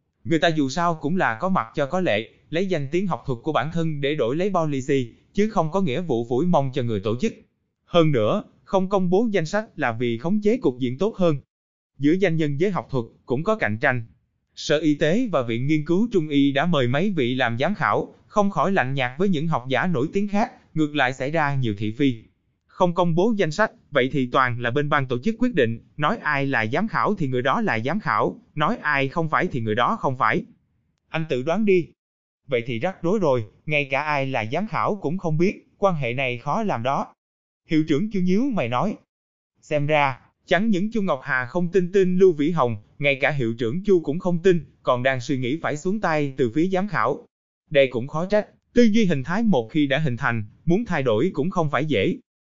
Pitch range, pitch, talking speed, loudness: 130-185 Hz, 155 Hz, 240 wpm, -23 LUFS